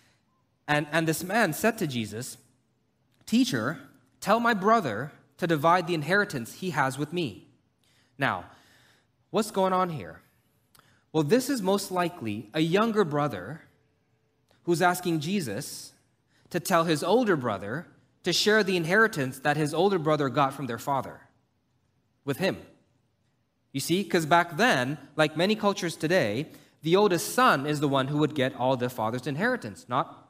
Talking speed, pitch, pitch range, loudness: 155 wpm, 150 Hz, 130-180 Hz, -26 LUFS